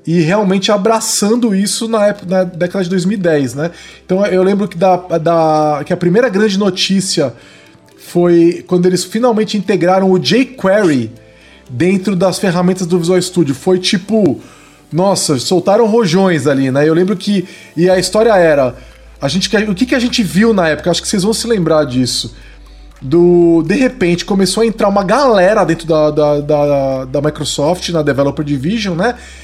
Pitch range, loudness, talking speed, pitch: 155-205 Hz, -12 LUFS, 170 wpm, 180 Hz